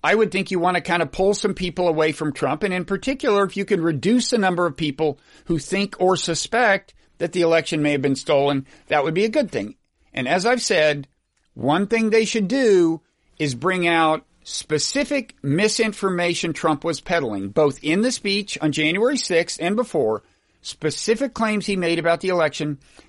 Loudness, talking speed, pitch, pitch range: -21 LUFS, 195 wpm, 175 Hz, 155-205 Hz